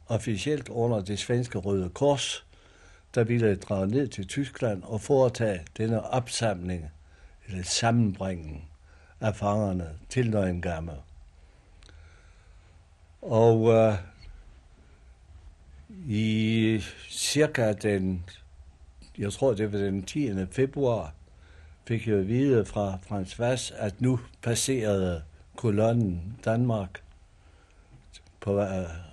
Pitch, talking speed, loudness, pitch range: 100 Hz, 95 wpm, -27 LUFS, 80-115 Hz